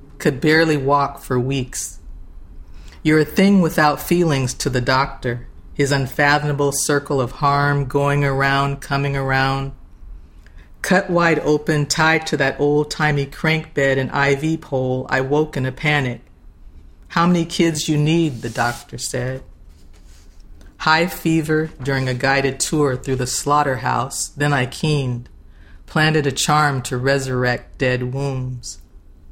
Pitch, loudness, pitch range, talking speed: 135 Hz, -18 LUFS, 125-150 Hz, 135 wpm